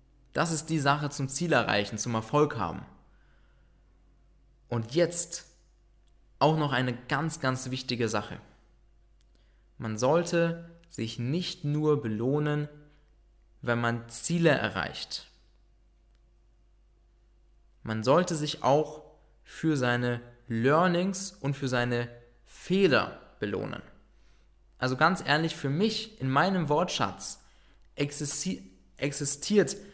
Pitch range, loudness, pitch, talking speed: 120-160 Hz, -27 LUFS, 140 Hz, 100 wpm